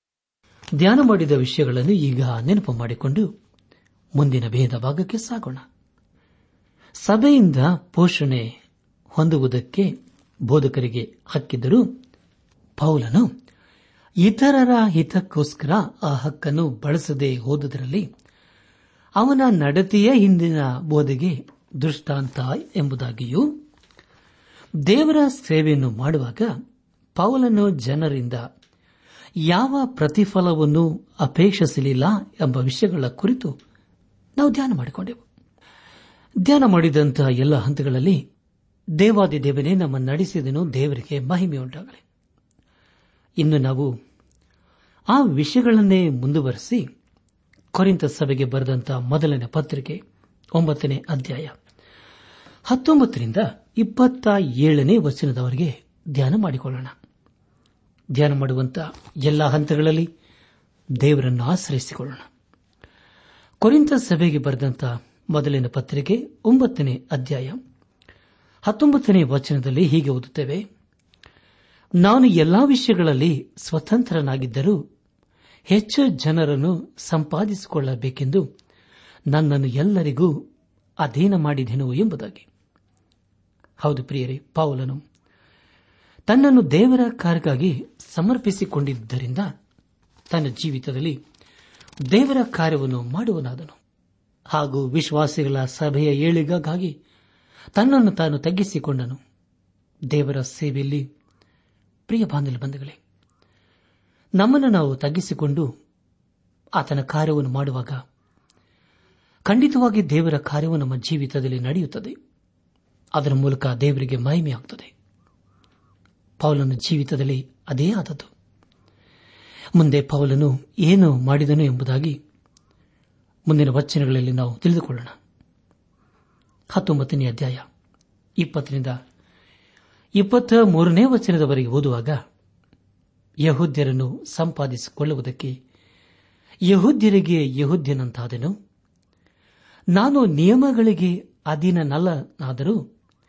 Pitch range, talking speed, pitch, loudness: 125-175 Hz, 65 wpm, 145 Hz, -20 LUFS